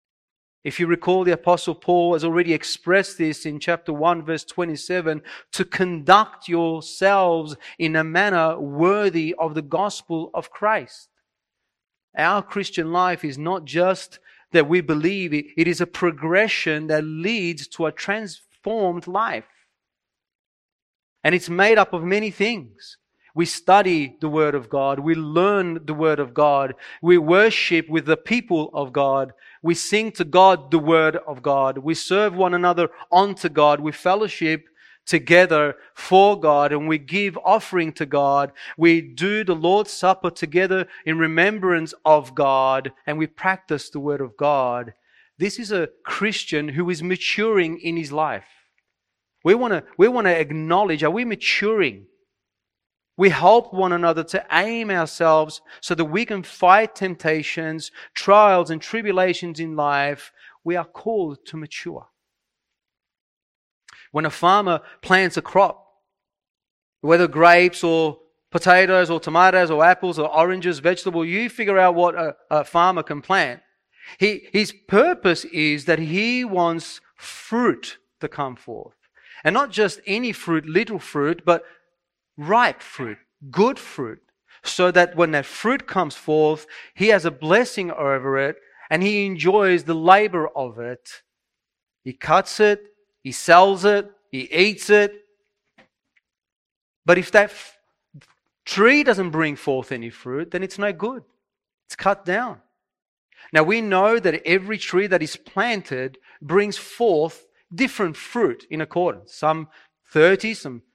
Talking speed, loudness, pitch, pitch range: 145 wpm, -20 LUFS, 175 Hz, 155-195 Hz